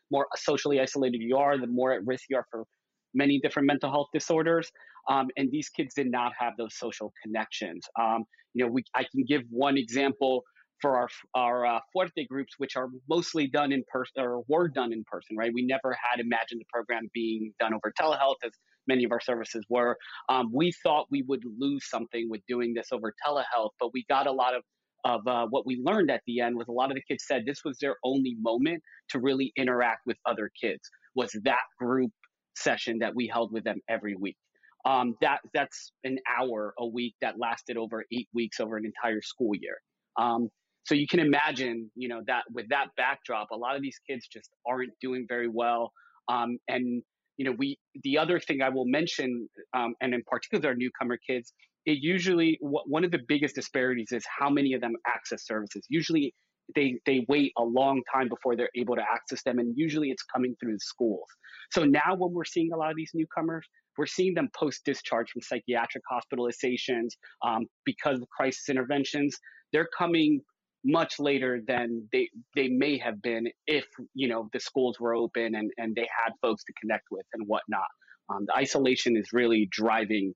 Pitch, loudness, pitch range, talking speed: 125 Hz, -29 LUFS, 120-140 Hz, 200 wpm